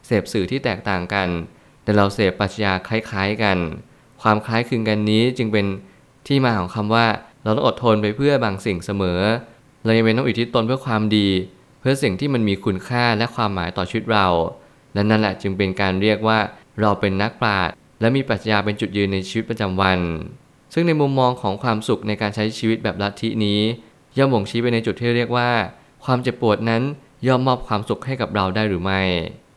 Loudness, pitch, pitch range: -20 LUFS, 110 Hz, 100-120 Hz